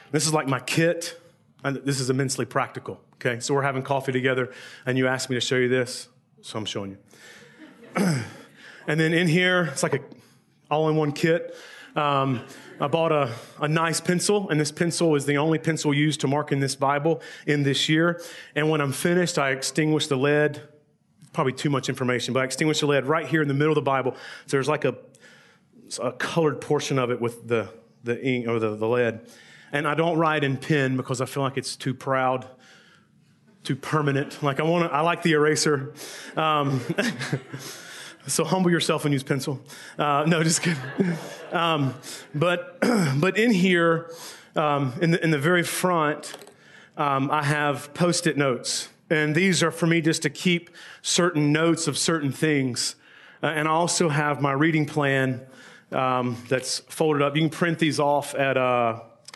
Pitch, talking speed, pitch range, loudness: 150 Hz, 190 wpm, 135-165 Hz, -24 LUFS